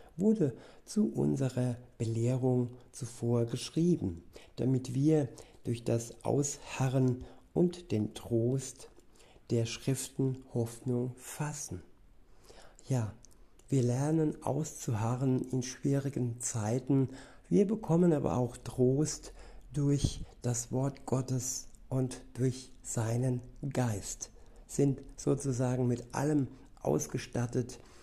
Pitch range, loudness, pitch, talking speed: 120-140 Hz, -33 LUFS, 130 Hz, 90 wpm